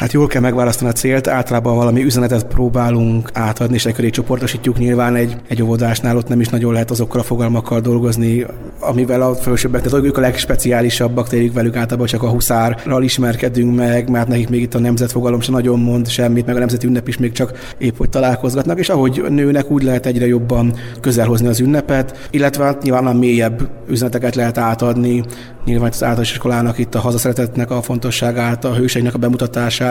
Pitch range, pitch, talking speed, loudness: 120-125 Hz, 120 Hz, 185 wpm, -15 LUFS